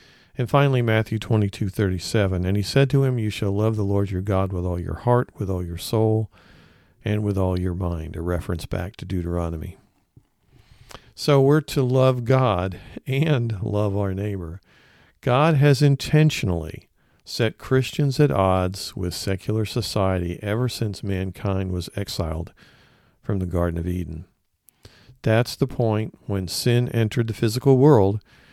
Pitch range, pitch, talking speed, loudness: 95-125 Hz, 105 Hz, 150 wpm, -22 LUFS